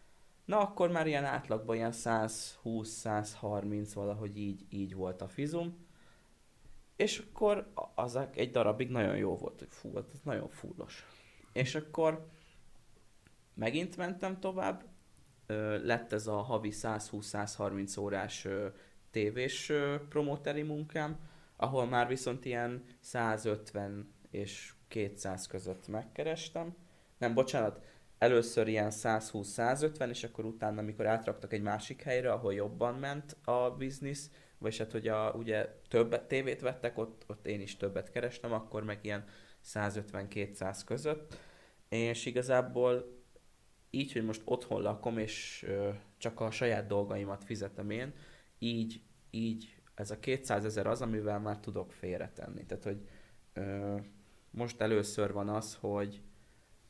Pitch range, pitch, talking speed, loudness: 105-125 Hz, 110 Hz, 130 wpm, -36 LUFS